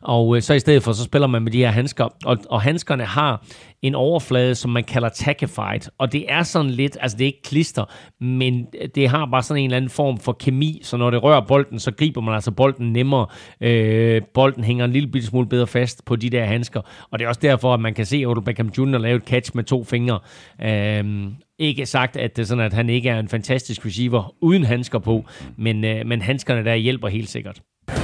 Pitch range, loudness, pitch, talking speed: 115-135 Hz, -20 LUFS, 125 Hz, 235 wpm